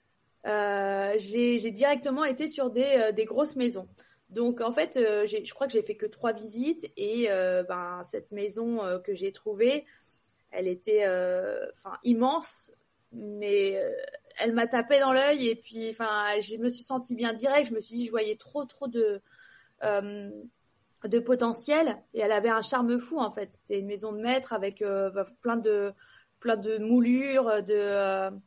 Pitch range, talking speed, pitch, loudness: 210-265 Hz, 185 wpm, 230 Hz, -28 LUFS